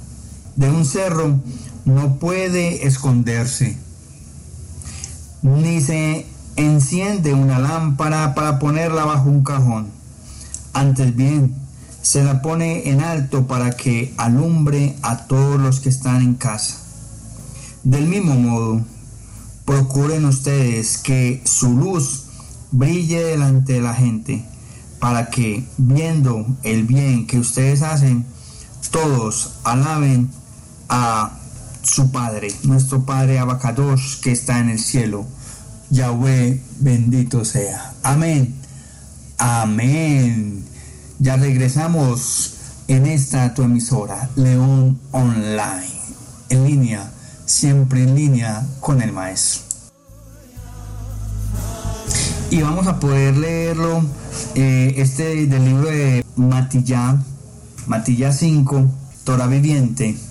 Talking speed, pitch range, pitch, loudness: 100 wpm, 120-140 Hz, 130 Hz, -17 LUFS